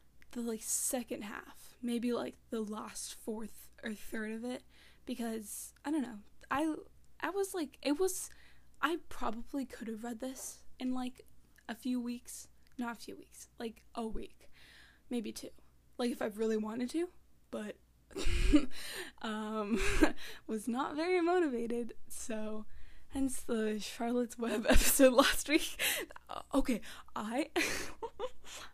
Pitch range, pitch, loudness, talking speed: 225-285 Hz, 245 Hz, -36 LUFS, 135 wpm